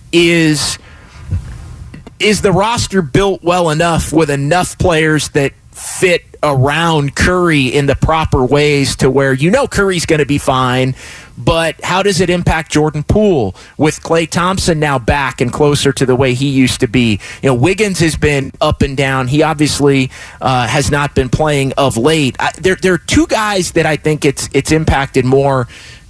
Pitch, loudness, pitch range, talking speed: 145 Hz, -12 LUFS, 130-165 Hz, 180 wpm